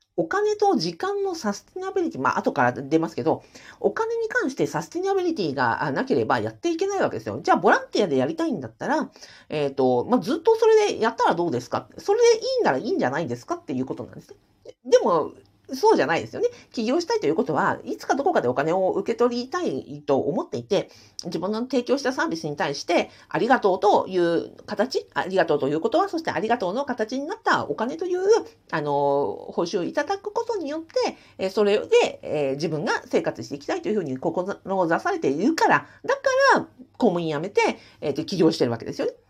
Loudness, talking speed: -24 LUFS, 440 characters per minute